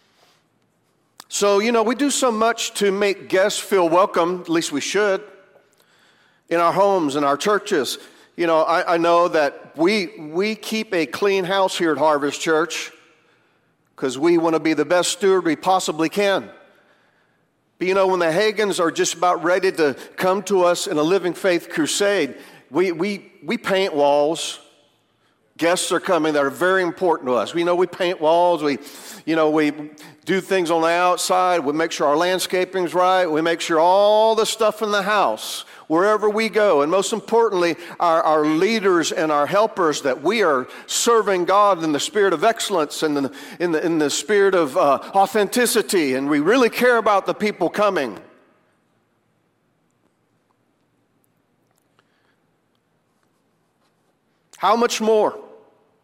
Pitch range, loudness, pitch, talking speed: 165-205 Hz, -19 LUFS, 185 Hz, 165 wpm